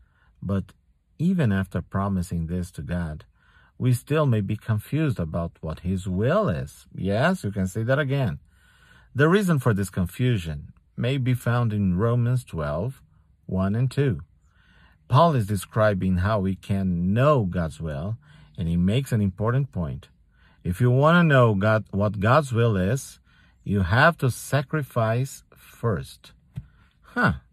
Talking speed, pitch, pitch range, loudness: 150 wpm, 105 Hz, 90-125 Hz, -24 LUFS